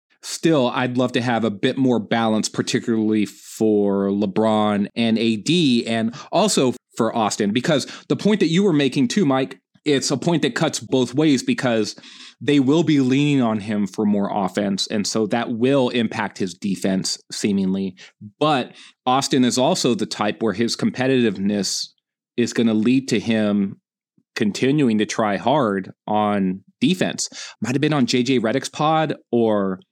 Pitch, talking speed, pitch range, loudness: 115 Hz, 160 wpm, 105-135 Hz, -20 LUFS